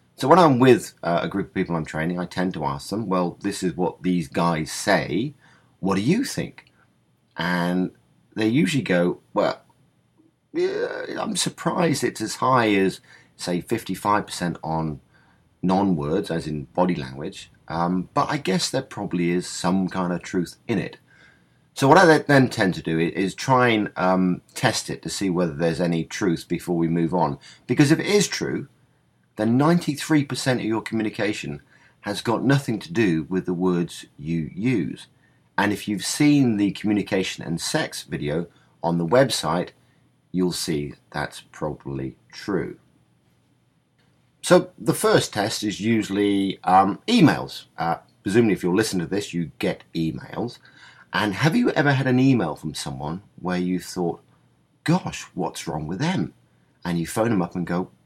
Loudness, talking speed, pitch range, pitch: -23 LUFS, 170 wpm, 85-115 Hz, 95 Hz